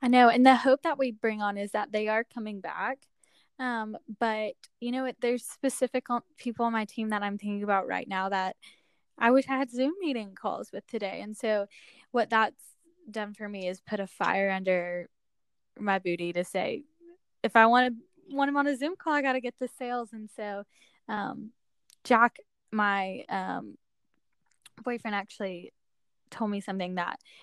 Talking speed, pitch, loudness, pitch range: 190 wpm, 225 Hz, -29 LUFS, 205-255 Hz